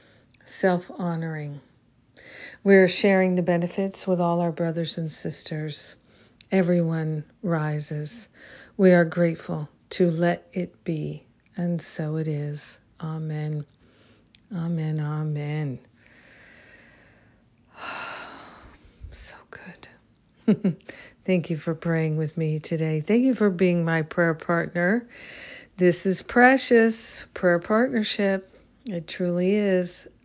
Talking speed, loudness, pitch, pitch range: 105 wpm, -24 LUFS, 170 Hz, 155-190 Hz